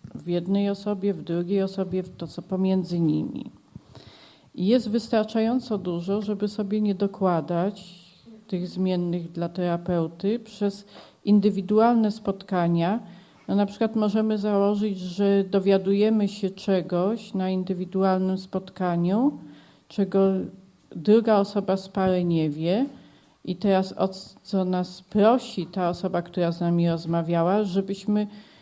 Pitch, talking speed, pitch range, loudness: 195 Hz, 115 wpm, 180-210 Hz, -25 LUFS